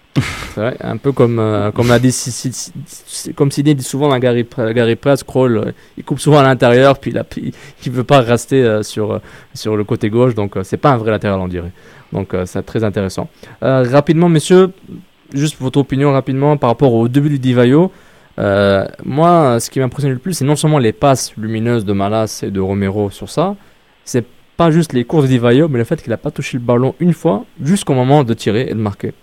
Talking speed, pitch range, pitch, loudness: 225 wpm, 110-145 Hz, 125 Hz, -14 LUFS